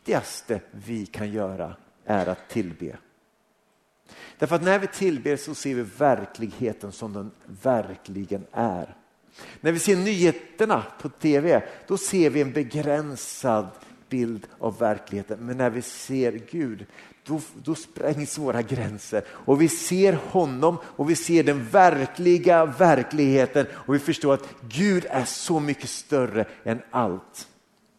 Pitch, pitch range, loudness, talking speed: 140 Hz, 115-165 Hz, -24 LUFS, 140 wpm